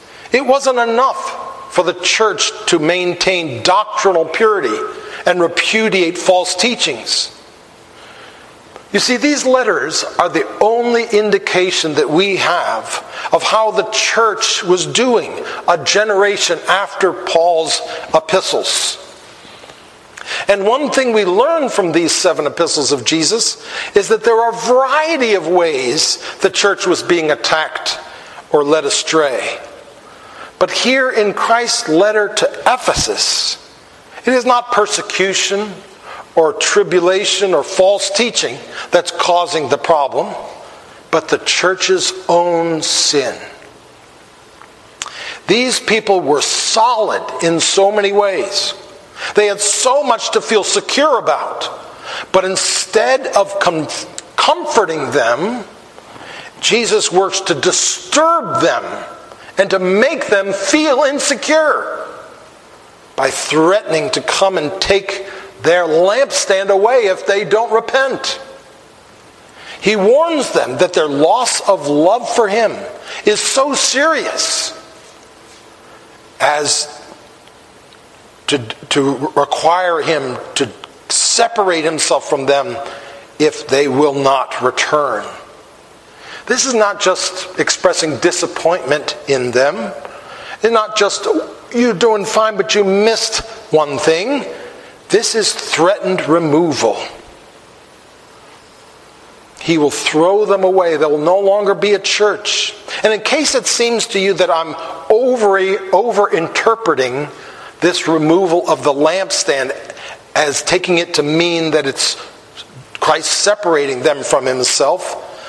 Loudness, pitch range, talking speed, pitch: -14 LUFS, 175-230 Hz, 115 wpm, 200 Hz